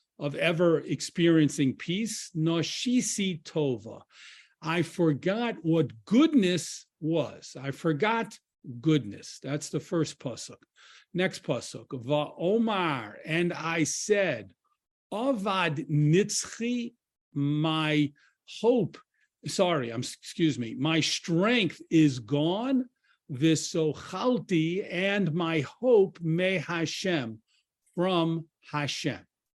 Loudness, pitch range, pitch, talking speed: -28 LUFS, 150-195 Hz, 165 Hz, 90 wpm